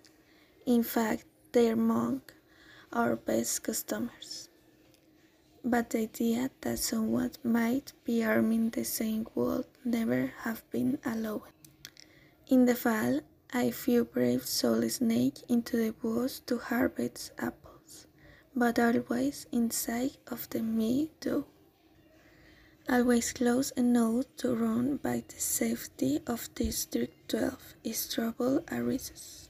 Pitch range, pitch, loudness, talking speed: 230-260 Hz, 240 Hz, -31 LUFS, 115 wpm